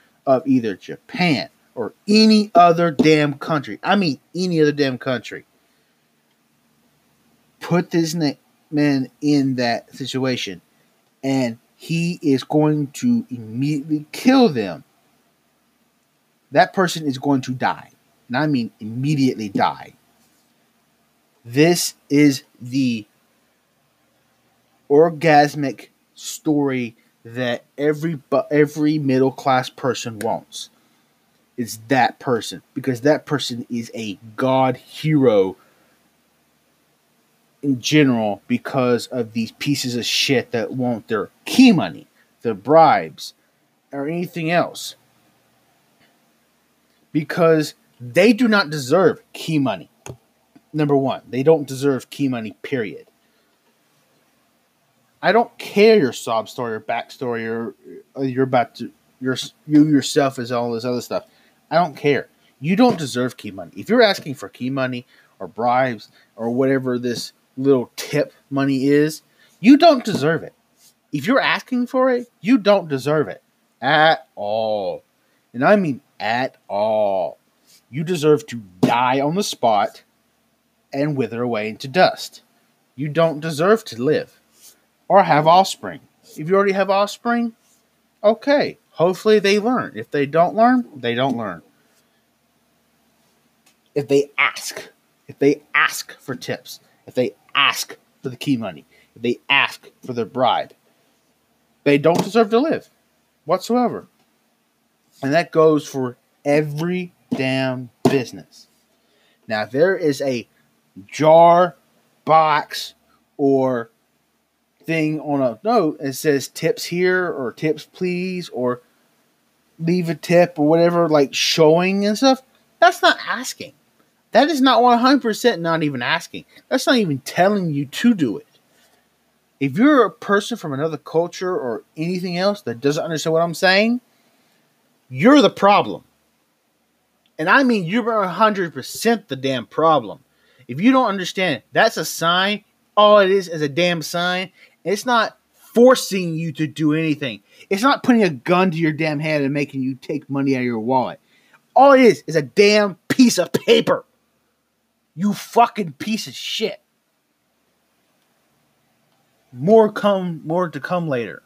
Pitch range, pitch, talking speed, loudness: 130-195 Hz, 155 Hz, 135 wpm, -18 LUFS